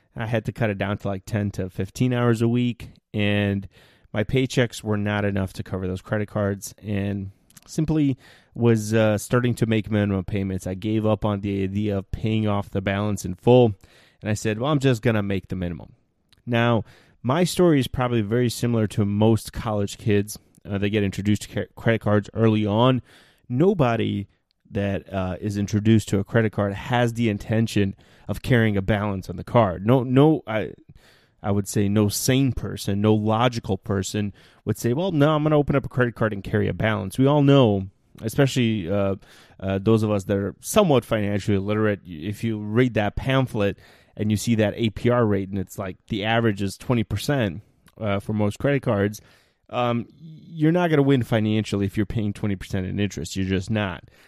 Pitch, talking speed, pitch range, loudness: 105 Hz, 205 wpm, 100-120 Hz, -23 LUFS